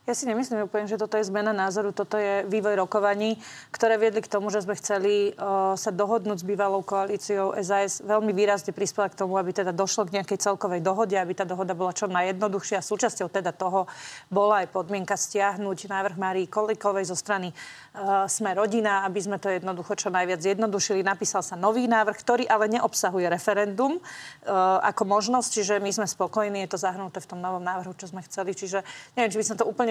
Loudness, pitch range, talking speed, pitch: -26 LUFS, 190-215 Hz, 195 wpm, 200 Hz